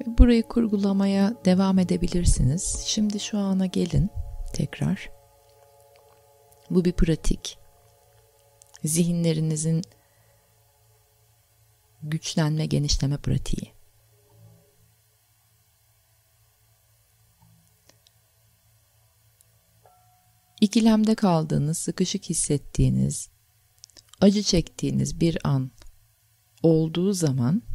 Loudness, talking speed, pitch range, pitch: -24 LUFS, 55 wpm, 110-170 Hz, 130 Hz